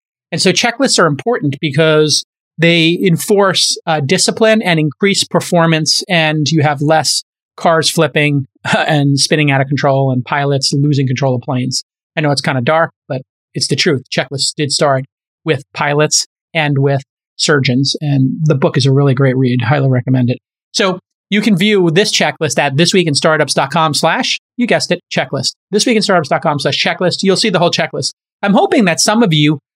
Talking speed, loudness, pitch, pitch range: 185 wpm, -13 LUFS, 155 Hz, 140-175 Hz